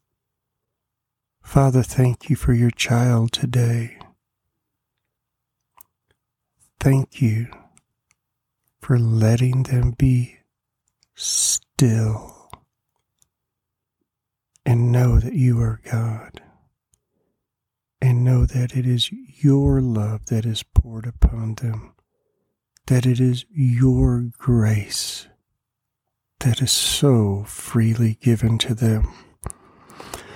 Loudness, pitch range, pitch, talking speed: -20 LUFS, 115-125 Hz, 120 Hz, 85 wpm